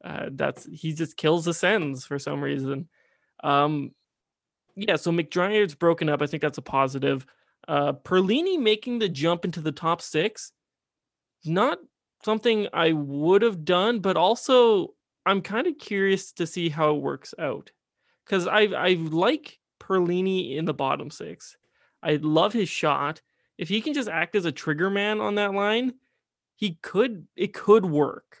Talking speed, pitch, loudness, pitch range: 165 wpm, 180 Hz, -25 LUFS, 155-210 Hz